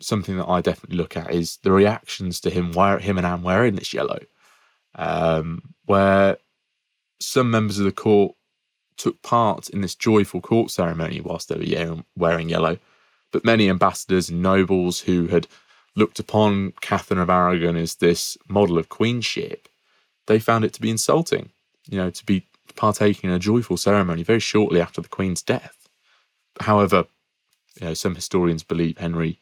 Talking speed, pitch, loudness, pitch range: 165 wpm, 95 Hz, -21 LUFS, 85-105 Hz